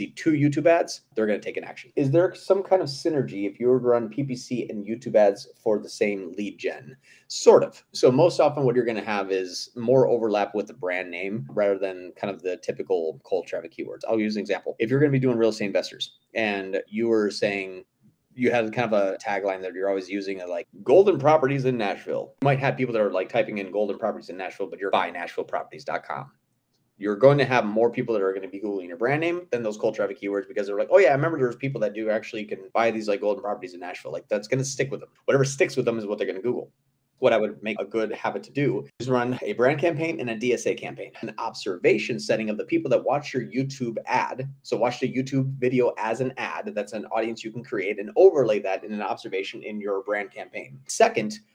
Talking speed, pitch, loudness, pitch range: 255 wpm, 125 Hz, -25 LUFS, 105-140 Hz